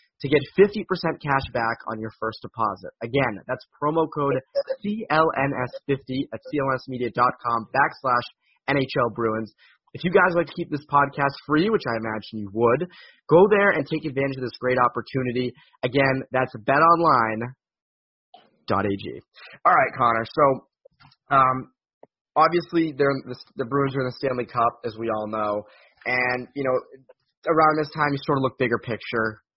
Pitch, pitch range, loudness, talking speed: 130 Hz, 120-150 Hz, -23 LUFS, 155 wpm